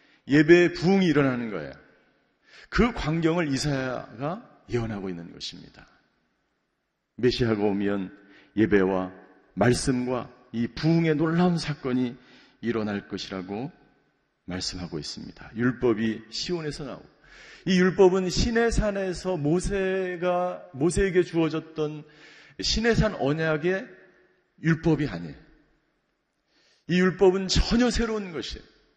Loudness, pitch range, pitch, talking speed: -25 LUFS, 120-180 Hz, 150 Hz, 255 characters per minute